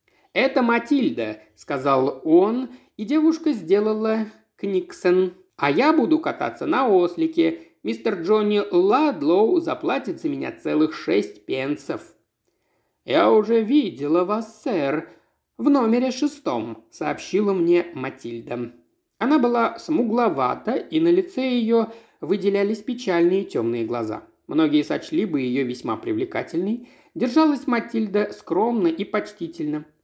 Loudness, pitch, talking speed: -22 LUFS, 230 Hz, 110 wpm